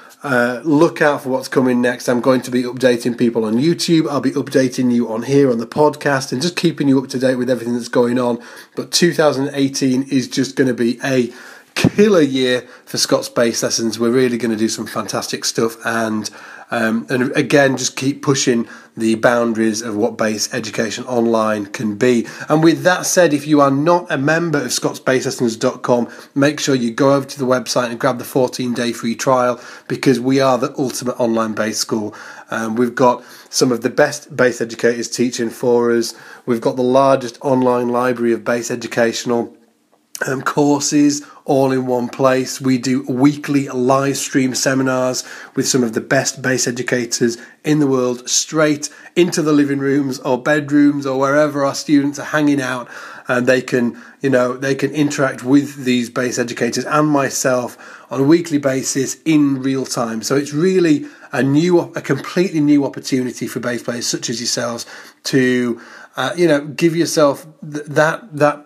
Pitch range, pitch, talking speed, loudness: 120-145 Hz, 130 Hz, 185 wpm, -17 LUFS